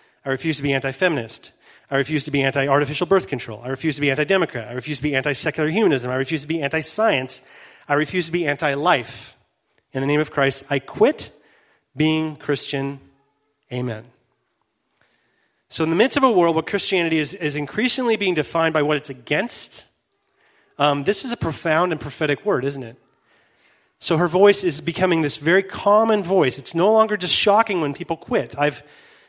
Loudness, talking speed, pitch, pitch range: -20 LUFS, 195 wpm, 150 Hz, 140-180 Hz